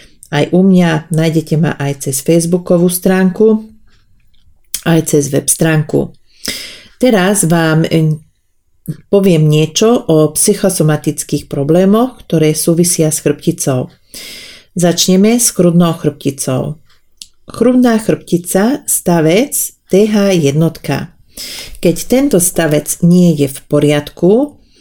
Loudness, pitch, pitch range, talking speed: -11 LUFS, 165 Hz, 150-185 Hz, 95 wpm